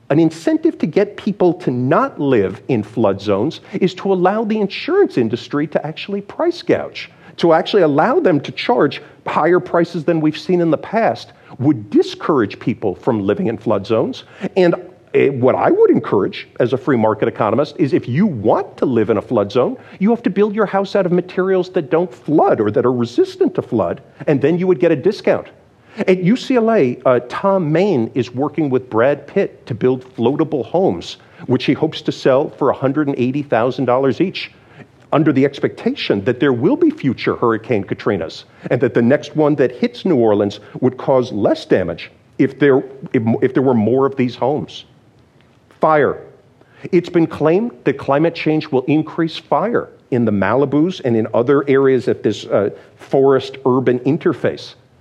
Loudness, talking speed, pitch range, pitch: -16 LUFS, 180 wpm, 130-195 Hz, 160 Hz